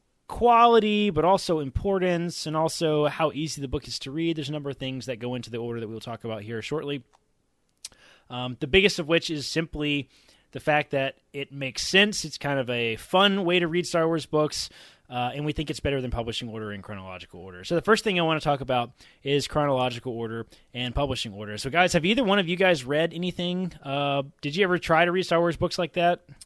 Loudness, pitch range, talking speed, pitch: -25 LUFS, 125-175 Hz, 230 wpm, 150 Hz